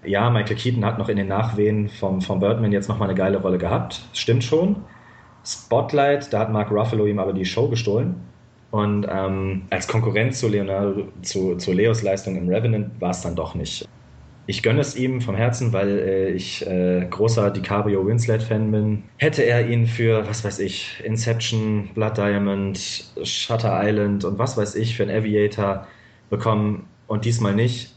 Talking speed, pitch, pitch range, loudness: 180 wpm, 105 Hz, 100-115 Hz, -22 LUFS